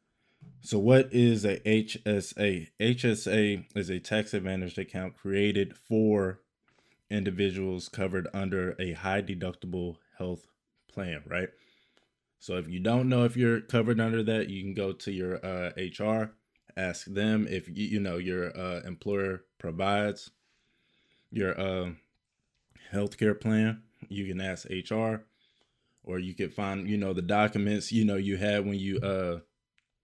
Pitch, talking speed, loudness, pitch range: 100 Hz, 145 wpm, -30 LUFS, 95-110 Hz